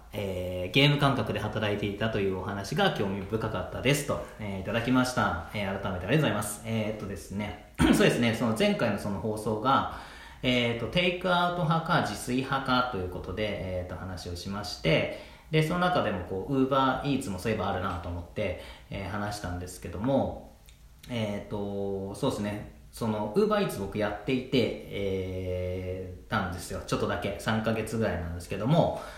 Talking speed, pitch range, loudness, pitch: 395 characters per minute, 95-125 Hz, -29 LUFS, 105 Hz